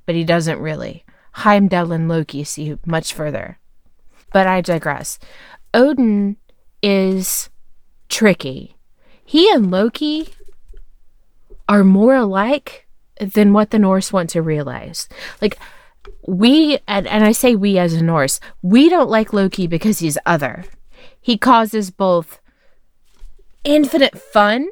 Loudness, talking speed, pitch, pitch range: -15 LUFS, 125 wpm, 200 Hz, 170-250 Hz